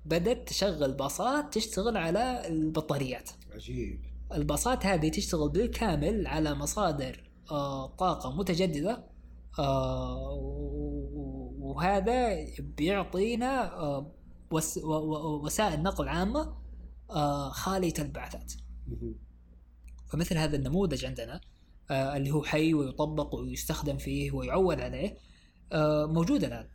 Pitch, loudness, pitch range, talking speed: 150 Hz, -31 LUFS, 135-180 Hz, 80 wpm